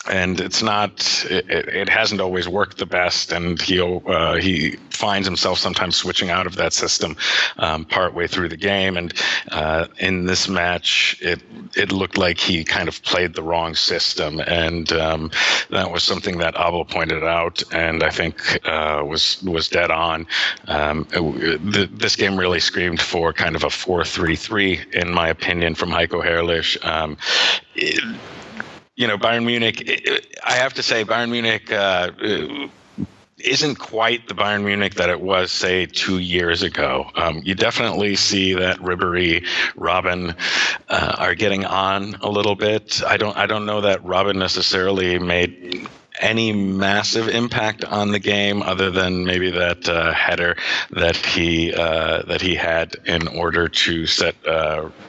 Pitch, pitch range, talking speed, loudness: 95 Hz, 85-100 Hz, 160 wpm, -19 LUFS